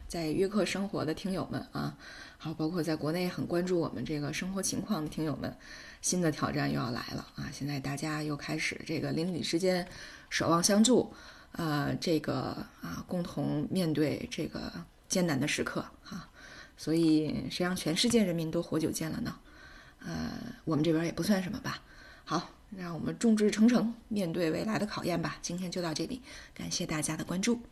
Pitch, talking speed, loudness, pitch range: 170 Hz, 280 characters per minute, -32 LUFS, 155-190 Hz